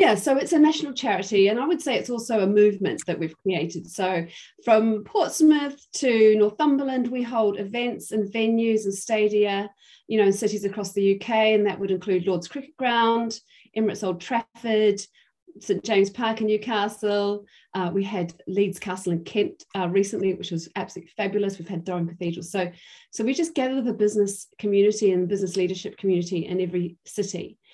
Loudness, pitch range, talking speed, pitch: -24 LUFS, 190-230 Hz, 180 wpm, 205 Hz